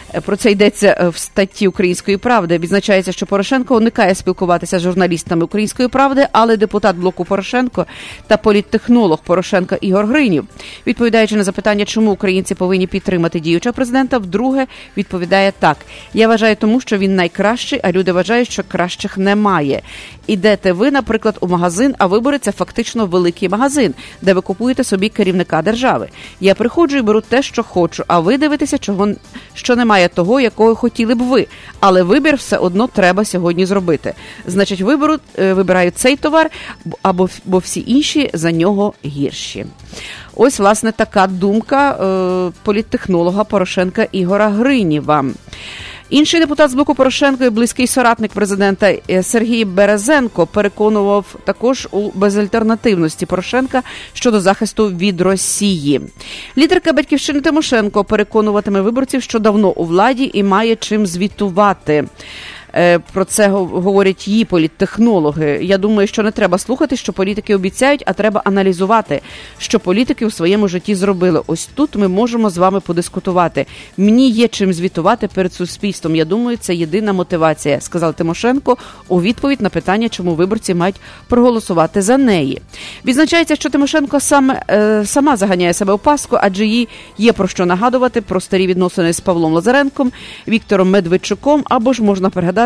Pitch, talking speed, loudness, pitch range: 205 Hz, 145 wpm, -14 LUFS, 185-235 Hz